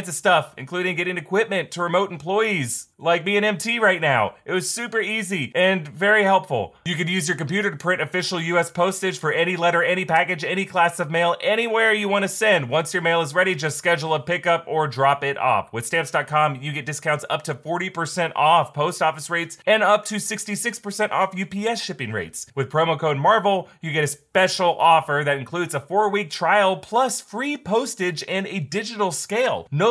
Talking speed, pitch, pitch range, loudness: 200 wpm, 175 Hz, 160-200 Hz, -21 LUFS